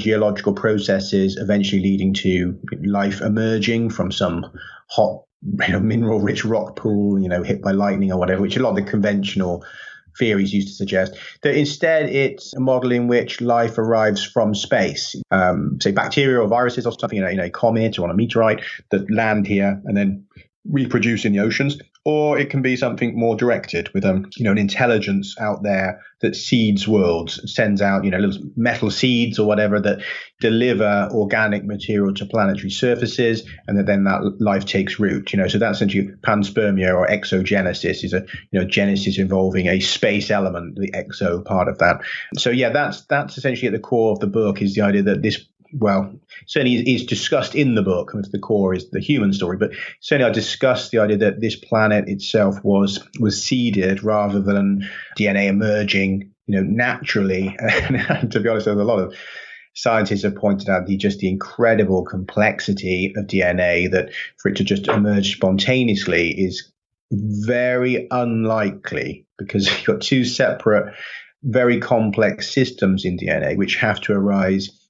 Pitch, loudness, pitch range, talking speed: 105 Hz, -19 LUFS, 100-115 Hz, 180 wpm